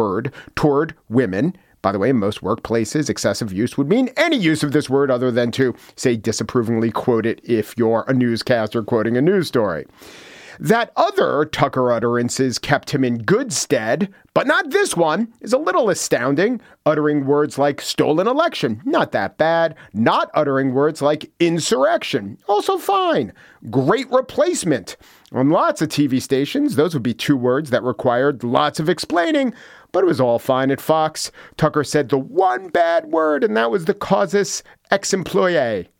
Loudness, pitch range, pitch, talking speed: -19 LUFS, 125-190 Hz, 145 Hz, 170 wpm